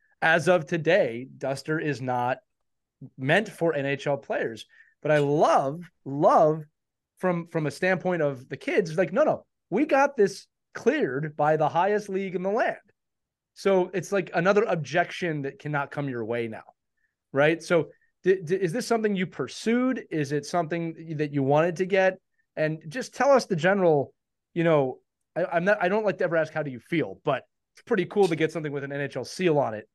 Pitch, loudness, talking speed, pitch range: 165 Hz, -26 LUFS, 195 wpm, 145-190 Hz